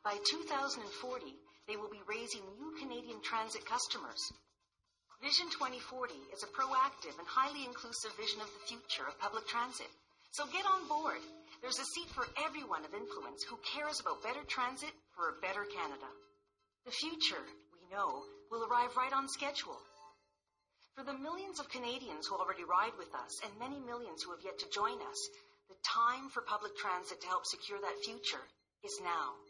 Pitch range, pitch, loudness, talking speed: 210-285 Hz, 245 Hz, -39 LUFS, 175 wpm